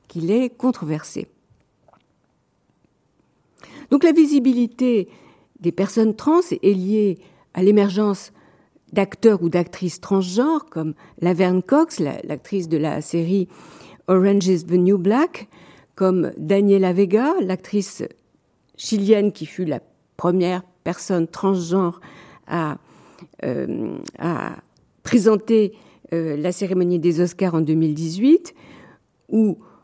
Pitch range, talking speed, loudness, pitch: 175-220 Hz, 105 wpm, -20 LUFS, 195 Hz